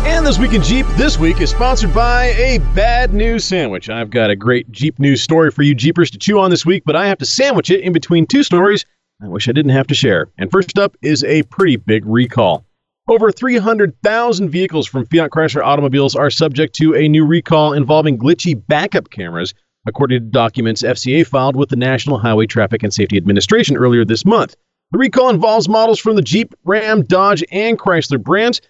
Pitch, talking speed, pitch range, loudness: 160 Hz, 205 wpm, 130-205 Hz, -13 LUFS